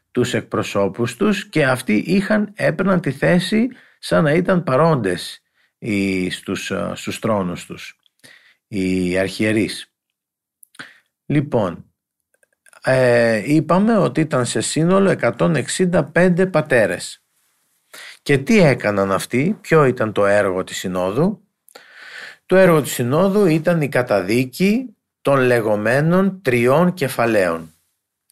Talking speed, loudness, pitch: 105 wpm, -18 LUFS, 130 Hz